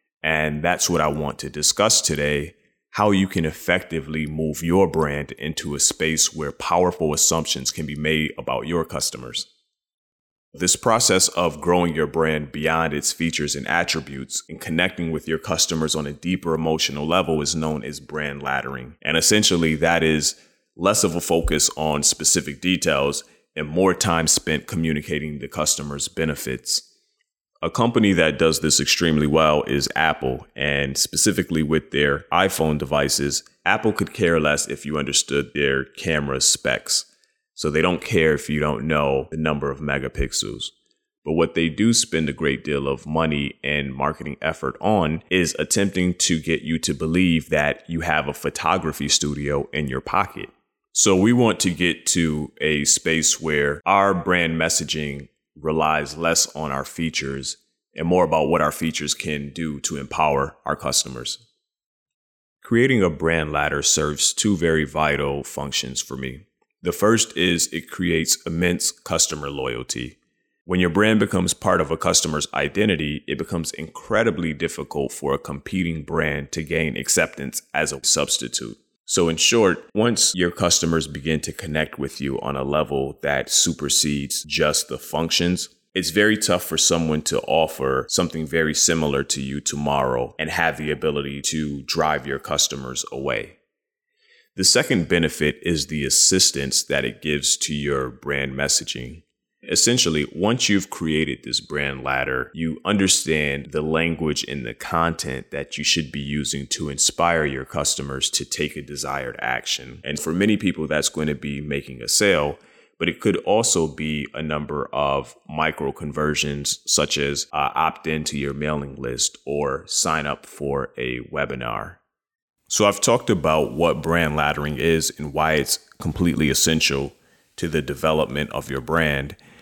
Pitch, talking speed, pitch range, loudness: 75 Hz, 160 wpm, 70-85 Hz, -21 LUFS